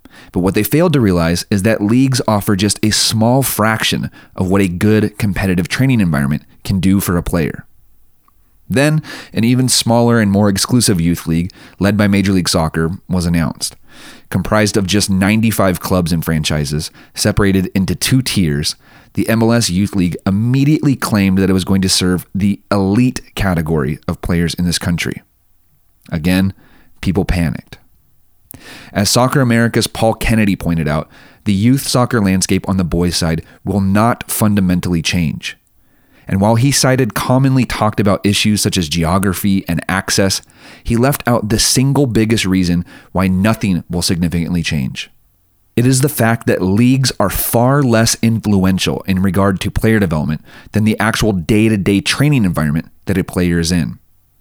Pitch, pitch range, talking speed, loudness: 100 Hz, 90-115 Hz, 160 wpm, -14 LUFS